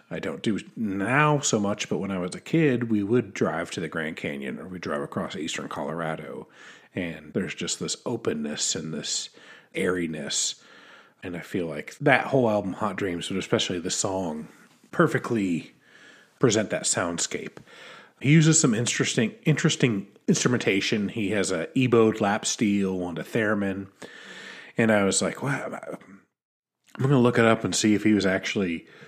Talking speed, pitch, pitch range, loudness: 170 wpm, 110 Hz, 95-130 Hz, -25 LUFS